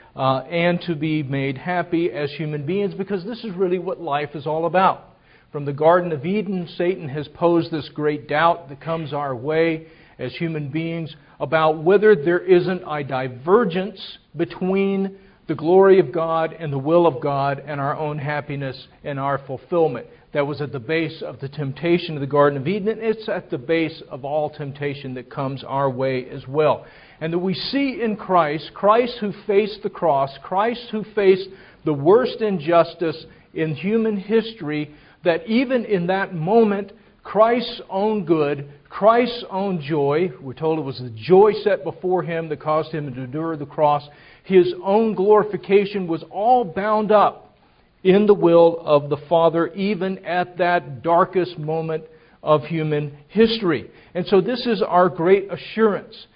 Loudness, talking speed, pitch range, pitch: -20 LUFS, 170 wpm, 150-195 Hz, 165 Hz